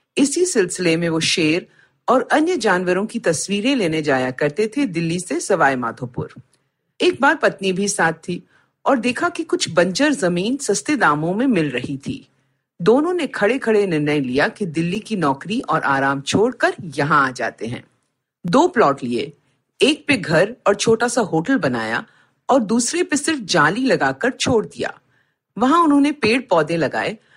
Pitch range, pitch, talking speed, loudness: 160-265 Hz, 200 Hz, 170 wpm, -18 LUFS